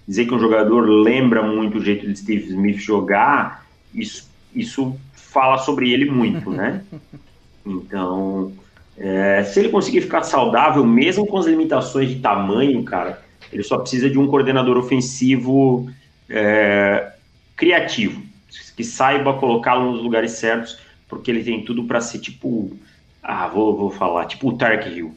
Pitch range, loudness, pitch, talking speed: 105-130 Hz, -18 LUFS, 120 Hz, 150 wpm